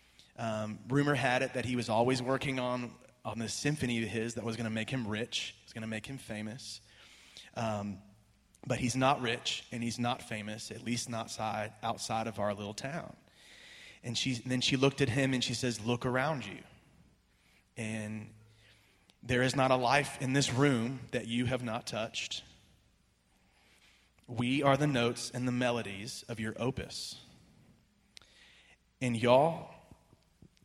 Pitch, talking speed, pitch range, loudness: 120 Hz, 170 wpm, 110-125 Hz, -33 LUFS